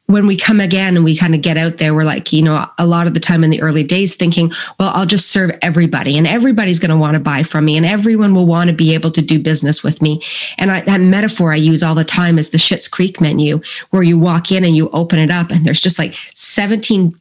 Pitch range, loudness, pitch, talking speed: 160-185 Hz, -12 LUFS, 170 Hz, 280 wpm